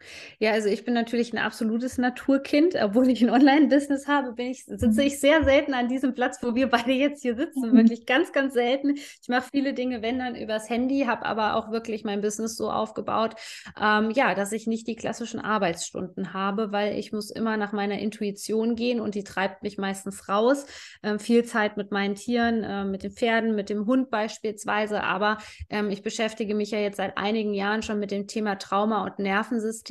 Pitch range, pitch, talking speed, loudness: 210-250 Hz, 225 Hz, 205 wpm, -25 LUFS